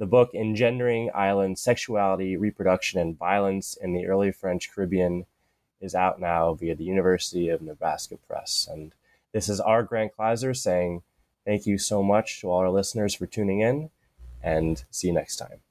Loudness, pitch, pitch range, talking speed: -26 LUFS, 95 Hz, 90-105 Hz, 170 wpm